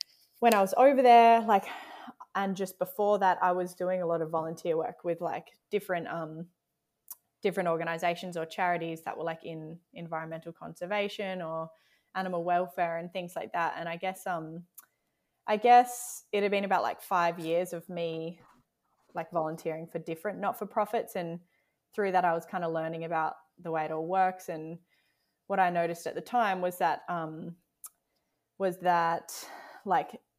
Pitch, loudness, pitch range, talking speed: 175 Hz, -30 LUFS, 165-195 Hz, 175 wpm